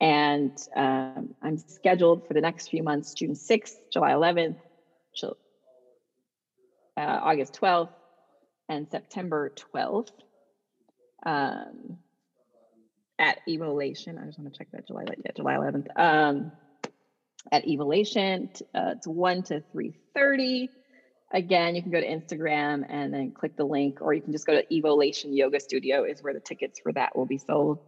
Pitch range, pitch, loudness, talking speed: 145-175 Hz, 155 Hz, -27 LUFS, 150 wpm